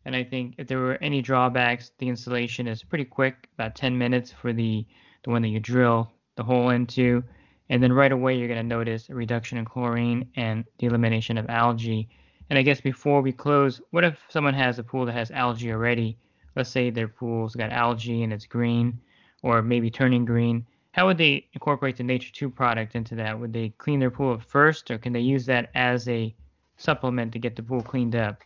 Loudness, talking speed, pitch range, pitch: -25 LUFS, 215 wpm, 115-130 Hz, 120 Hz